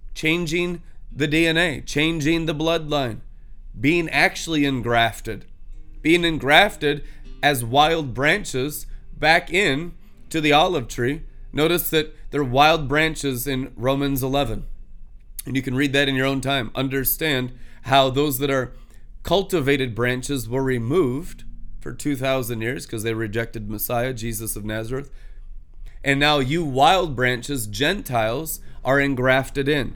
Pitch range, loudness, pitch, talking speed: 120-150 Hz, -21 LUFS, 135 Hz, 130 wpm